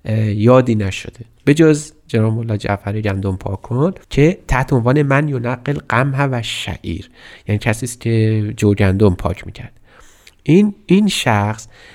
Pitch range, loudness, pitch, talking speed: 105-140 Hz, -16 LUFS, 115 Hz, 145 wpm